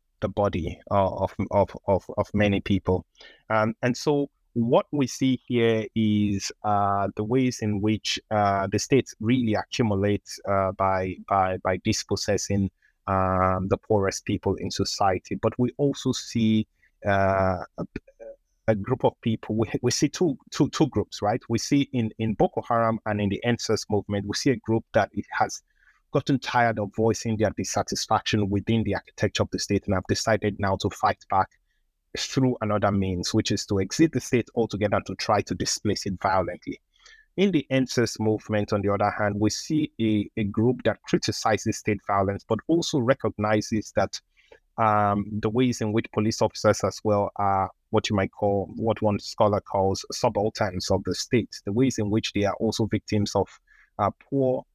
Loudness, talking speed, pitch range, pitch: -25 LUFS, 180 wpm, 100-120 Hz, 105 Hz